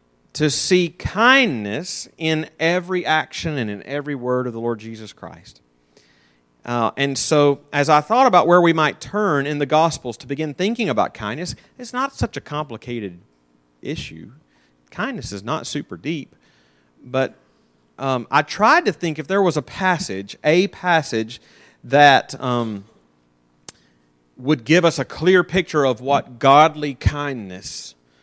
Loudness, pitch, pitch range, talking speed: -19 LUFS, 140 Hz, 100-160 Hz, 150 wpm